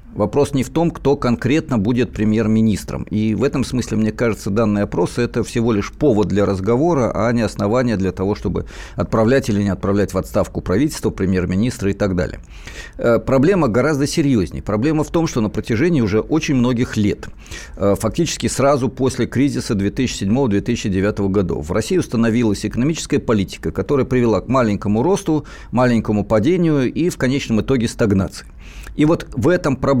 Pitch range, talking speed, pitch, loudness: 100-135 Hz, 160 wpm, 115 Hz, -18 LUFS